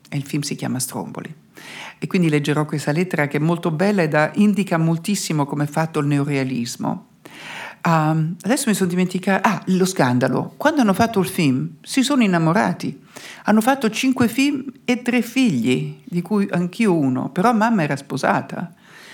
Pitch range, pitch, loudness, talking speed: 150-220 Hz, 180 Hz, -19 LUFS, 170 wpm